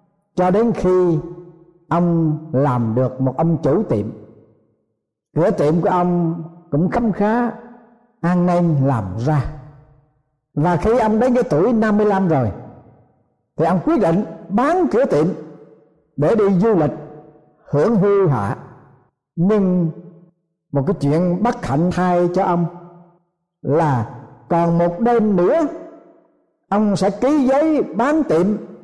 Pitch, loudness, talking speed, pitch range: 175 Hz, -18 LUFS, 130 wpm, 150-205 Hz